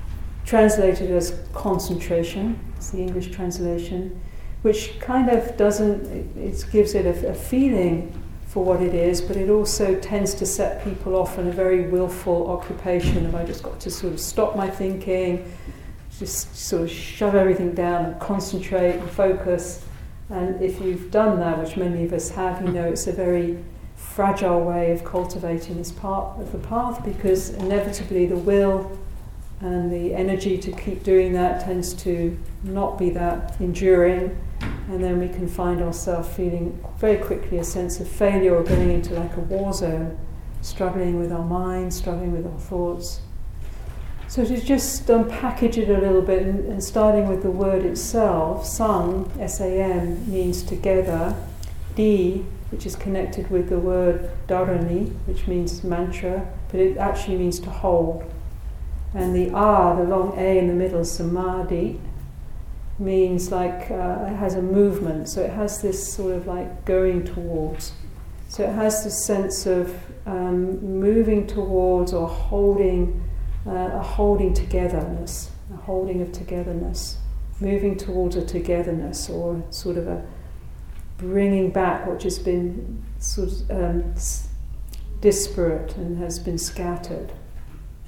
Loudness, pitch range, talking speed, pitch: -23 LUFS, 175-195 Hz, 155 wpm, 180 Hz